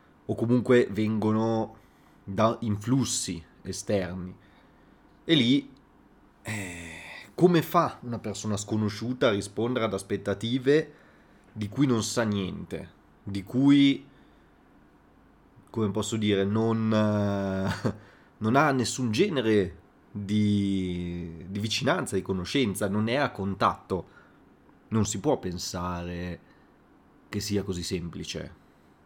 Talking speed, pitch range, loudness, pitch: 105 wpm, 95-115 Hz, -27 LUFS, 105 Hz